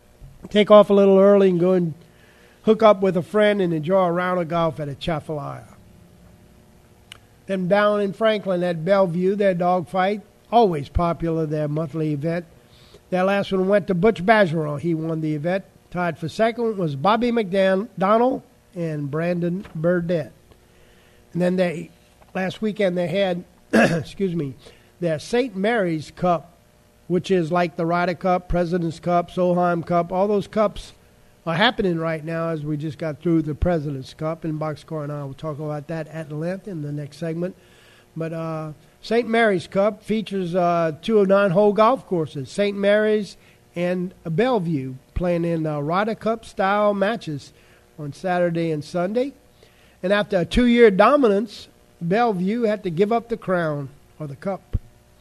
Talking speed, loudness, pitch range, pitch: 165 wpm, -21 LUFS, 160-200 Hz, 180 Hz